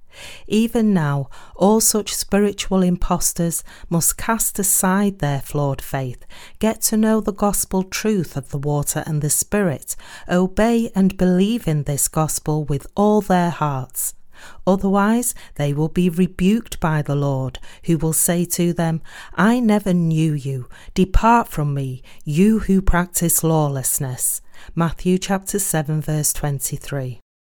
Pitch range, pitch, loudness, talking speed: 145-200 Hz, 175 Hz, -19 LUFS, 140 wpm